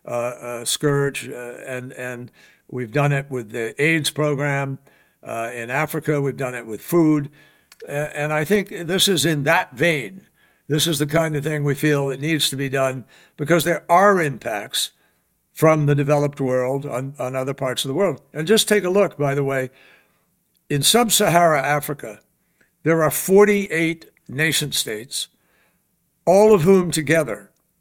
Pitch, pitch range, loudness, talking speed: 150 Hz, 135-165 Hz, -20 LUFS, 170 wpm